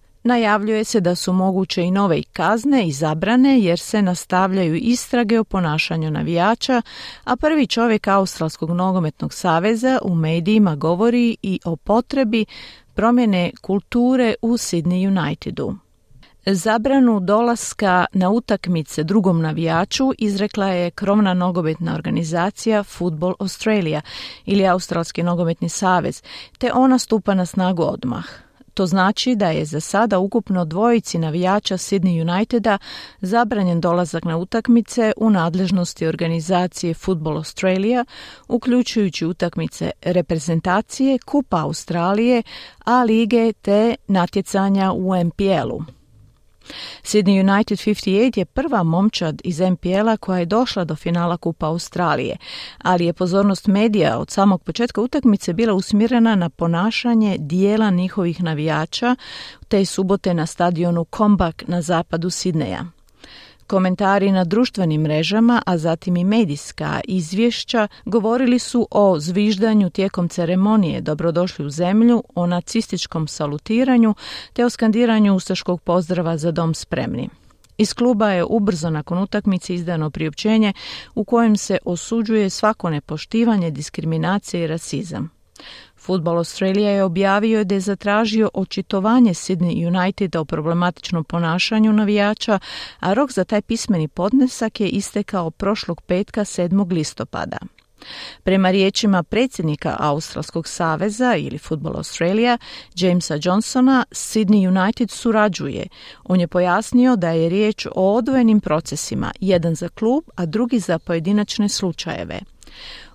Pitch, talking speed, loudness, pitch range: 190 Hz, 120 wpm, -19 LUFS, 175-220 Hz